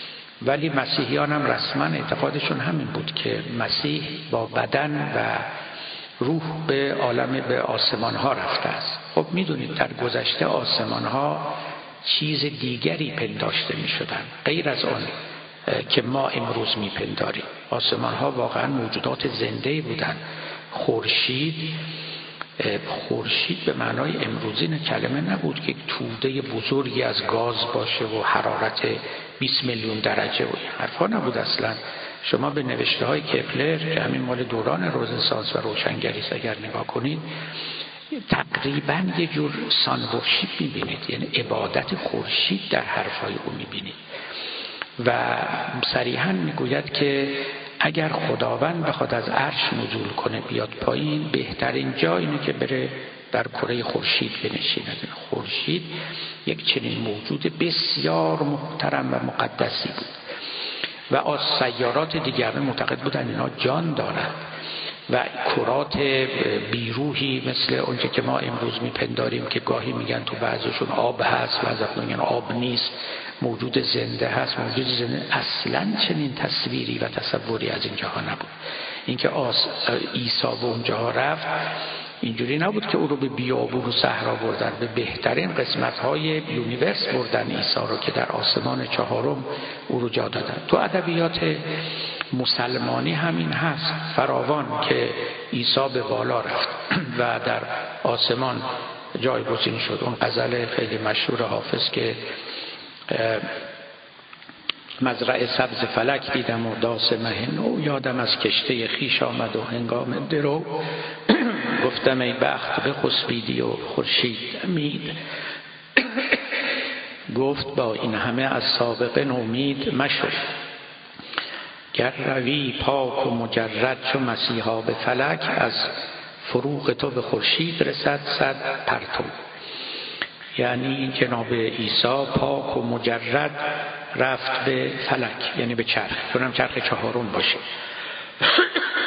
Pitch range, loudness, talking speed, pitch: 115-145 Hz, -24 LUFS, 125 wpm, 130 Hz